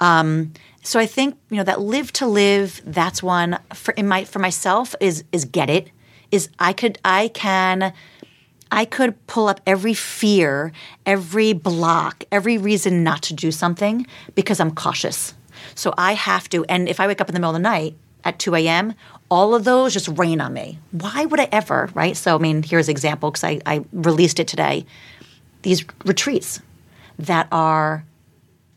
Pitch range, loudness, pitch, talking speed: 160-205 Hz, -19 LUFS, 180 Hz, 185 wpm